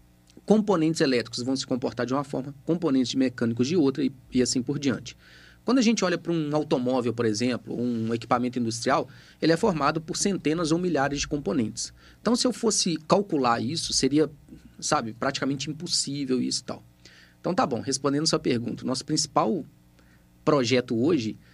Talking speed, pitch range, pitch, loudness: 175 wpm, 120-160 Hz, 135 Hz, -26 LUFS